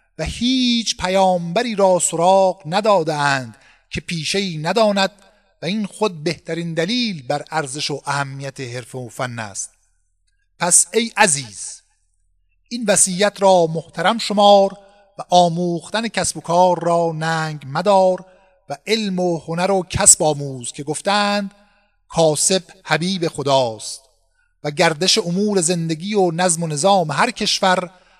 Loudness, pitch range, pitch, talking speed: -17 LUFS, 155-200 Hz, 180 Hz, 130 wpm